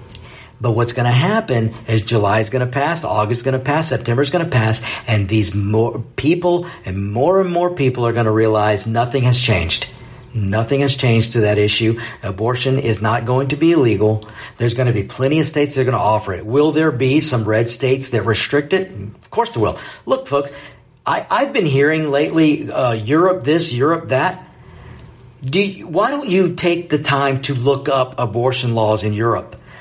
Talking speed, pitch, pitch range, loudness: 205 wpm, 125 Hz, 115-145 Hz, -17 LUFS